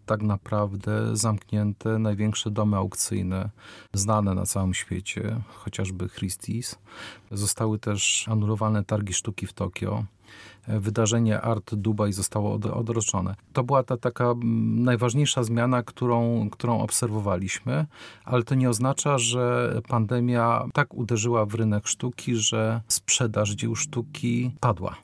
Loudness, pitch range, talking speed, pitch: -25 LUFS, 105-120 Hz, 115 wpm, 110 Hz